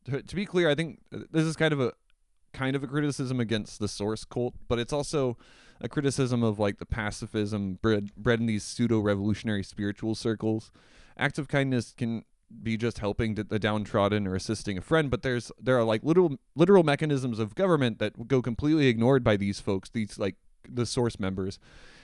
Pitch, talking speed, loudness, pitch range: 115 Hz, 190 wpm, -28 LUFS, 105-135 Hz